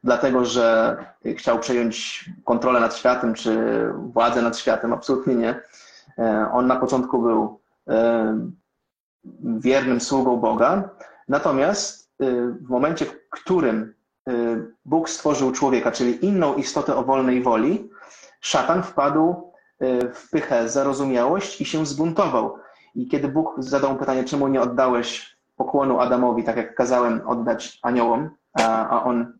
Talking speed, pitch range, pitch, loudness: 120 wpm, 115-140 Hz, 125 Hz, -21 LUFS